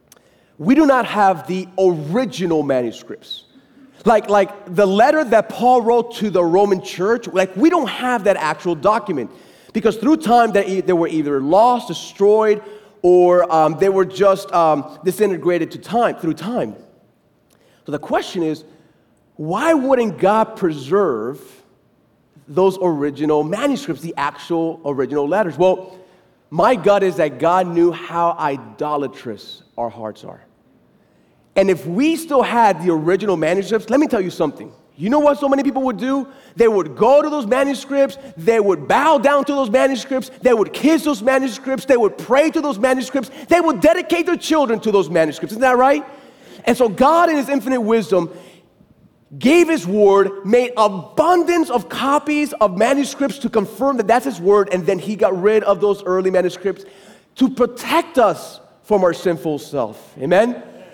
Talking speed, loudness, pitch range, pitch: 165 wpm, -17 LUFS, 180-265 Hz, 210 Hz